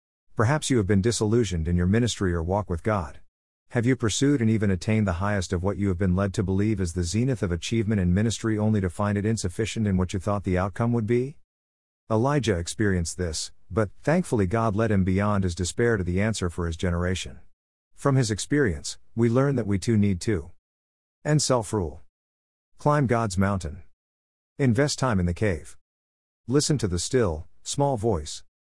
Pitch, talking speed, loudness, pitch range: 100 Hz, 190 wpm, -25 LUFS, 85-115 Hz